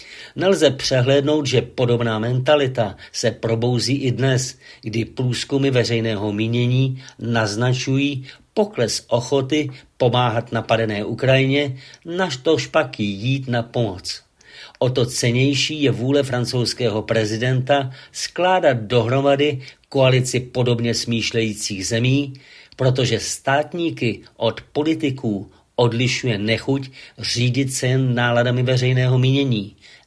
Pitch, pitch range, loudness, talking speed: 125 Hz, 115-135 Hz, -20 LUFS, 100 wpm